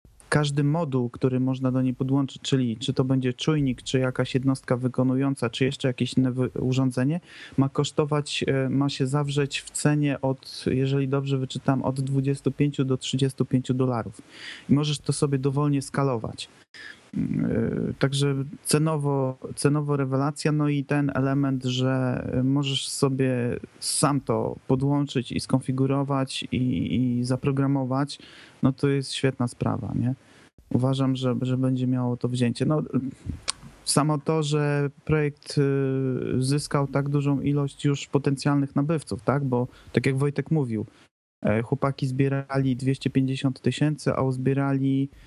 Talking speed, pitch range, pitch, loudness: 130 wpm, 130-140 Hz, 135 Hz, -25 LUFS